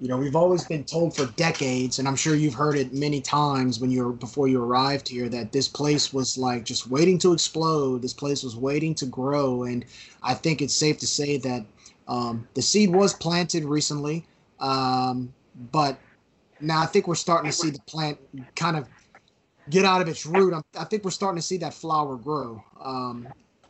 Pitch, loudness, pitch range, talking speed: 140 Hz, -24 LUFS, 130-160 Hz, 200 wpm